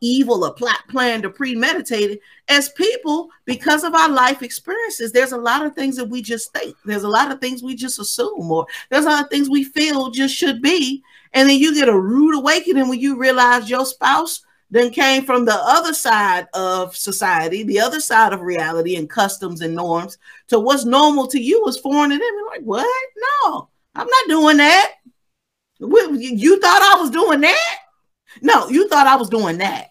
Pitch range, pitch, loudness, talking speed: 230-305 Hz, 270 Hz, -16 LUFS, 200 wpm